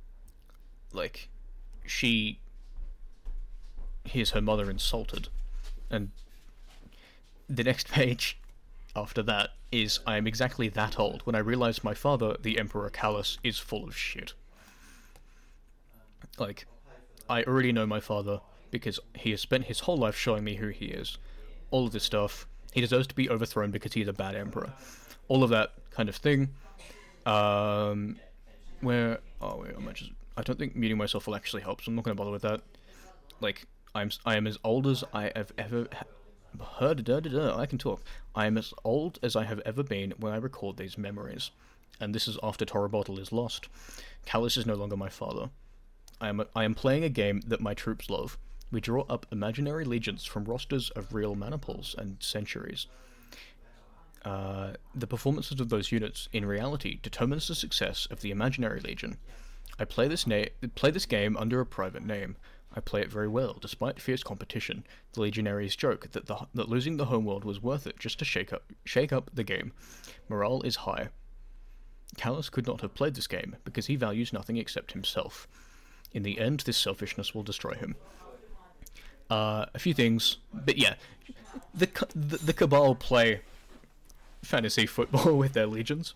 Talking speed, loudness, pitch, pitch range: 175 wpm, -31 LUFS, 110 Hz, 105-125 Hz